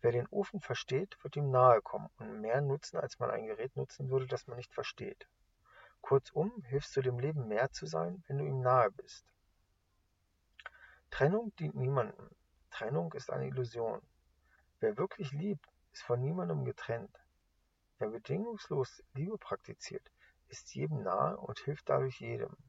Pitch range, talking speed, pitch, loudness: 110-155 Hz, 155 wpm, 130 Hz, -36 LUFS